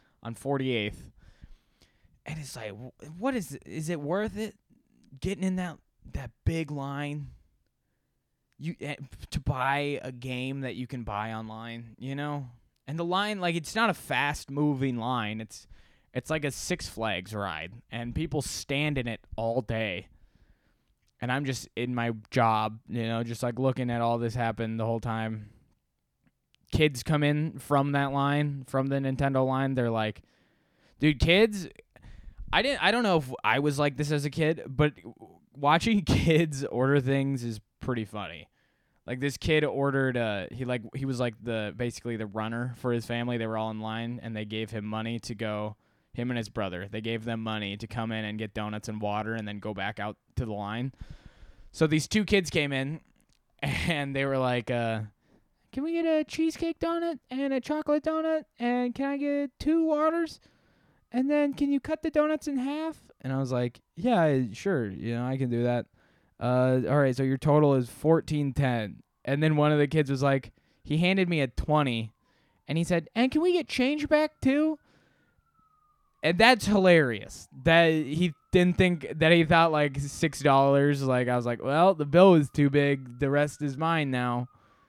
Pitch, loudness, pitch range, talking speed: 135 Hz, -28 LUFS, 115-165 Hz, 190 wpm